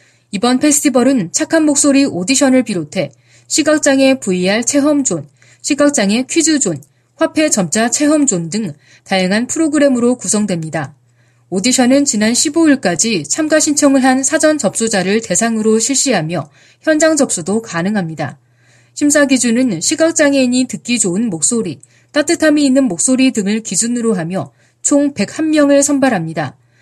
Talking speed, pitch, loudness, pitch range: 310 characters per minute, 240 Hz, -13 LUFS, 180-285 Hz